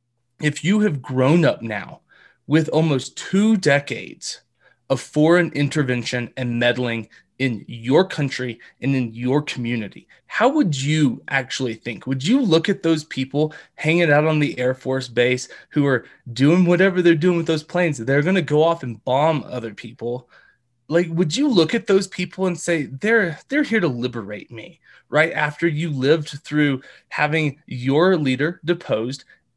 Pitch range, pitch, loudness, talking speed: 125-170 Hz, 150 Hz, -20 LUFS, 165 wpm